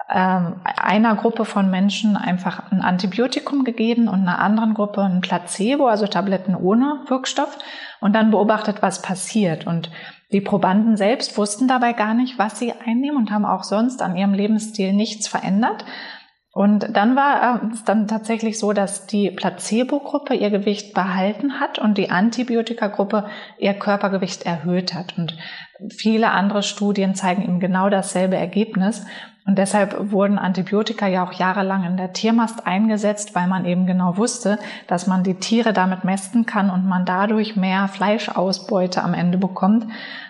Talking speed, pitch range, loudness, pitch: 155 wpm, 185-225 Hz, -20 LUFS, 205 Hz